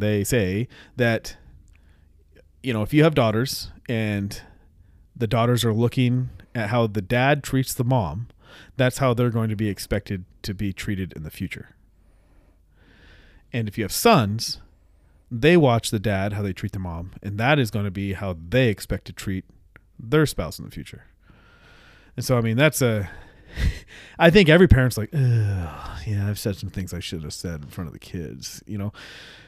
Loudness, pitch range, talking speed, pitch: -23 LUFS, 95-120 Hz, 185 wpm, 105 Hz